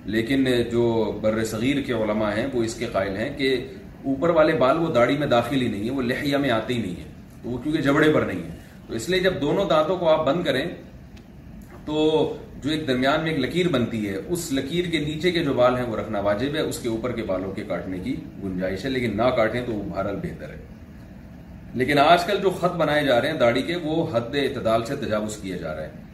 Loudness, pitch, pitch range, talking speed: -23 LUFS, 130 Hz, 110-155 Hz, 240 wpm